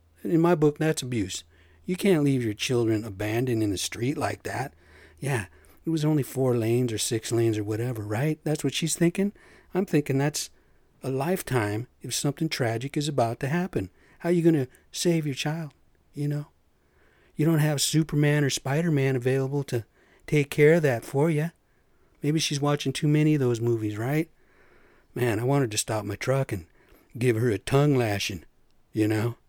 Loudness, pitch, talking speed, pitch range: -26 LUFS, 135 Hz, 190 wpm, 110-150 Hz